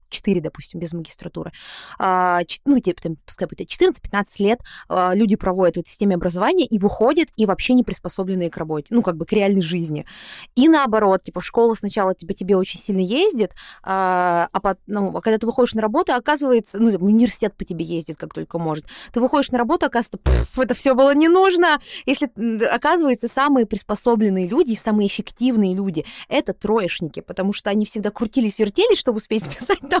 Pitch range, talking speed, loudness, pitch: 185-250 Hz, 180 wpm, -19 LUFS, 210 Hz